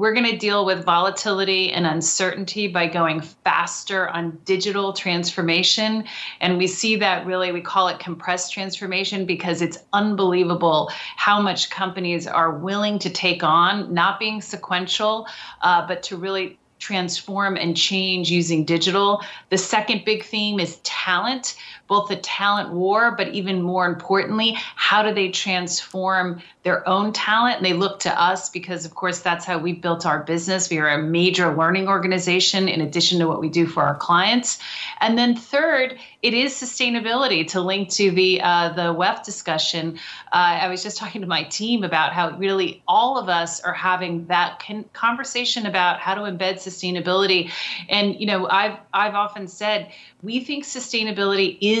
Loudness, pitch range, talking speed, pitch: -20 LUFS, 175-205 Hz, 170 wpm, 190 Hz